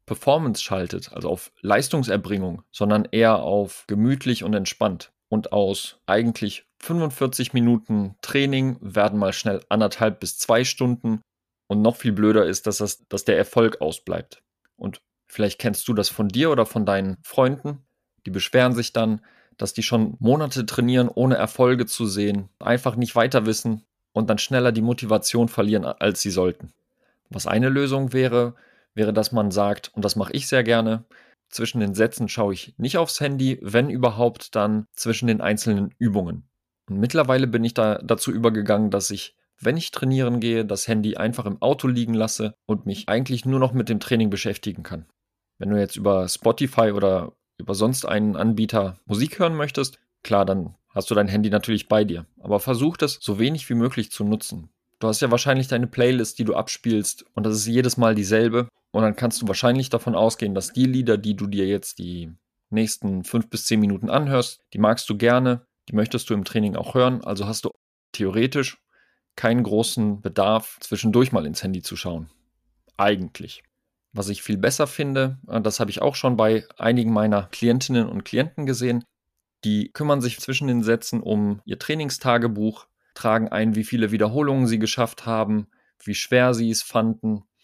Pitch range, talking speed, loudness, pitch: 105-125 Hz, 180 wpm, -22 LUFS, 110 Hz